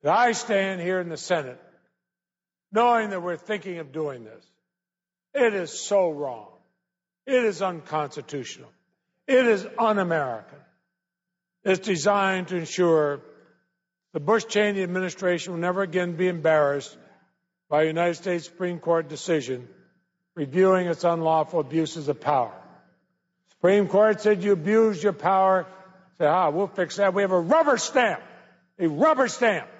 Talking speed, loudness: 135 wpm, -24 LUFS